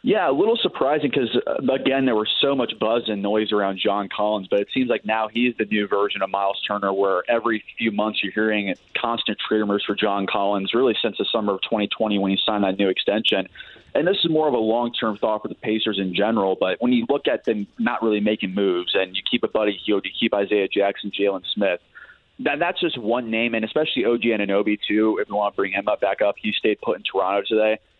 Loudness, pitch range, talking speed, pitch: -22 LUFS, 100-115 Hz, 240 wpm, 110 Hz